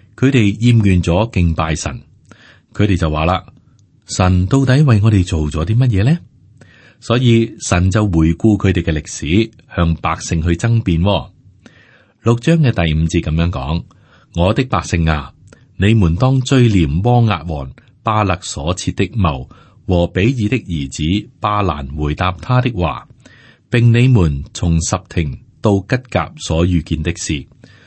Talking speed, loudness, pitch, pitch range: 210 characters per minute, -15 LUFS, 95 Hz, 85-115 Hz